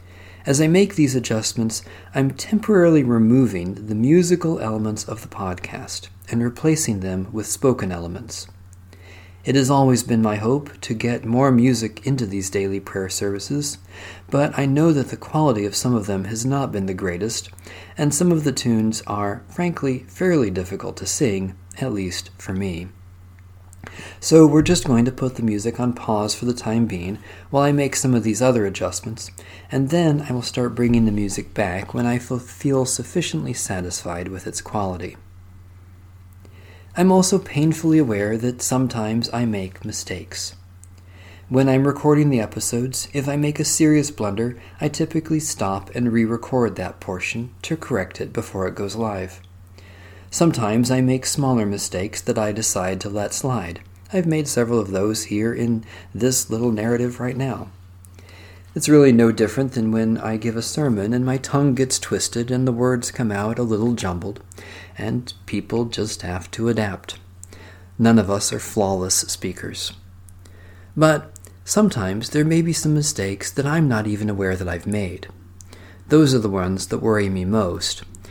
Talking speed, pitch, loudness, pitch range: 170 wpm, 110 Hz, -21 LUFS, 95-130 Hz